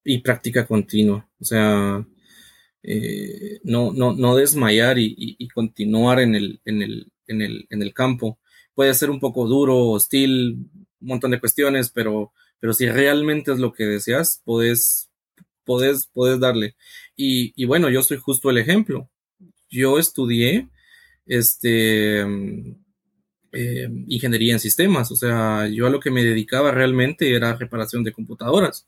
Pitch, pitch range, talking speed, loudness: 125 Hz, 115-135 Hz, 150 wpm, -19 LUFS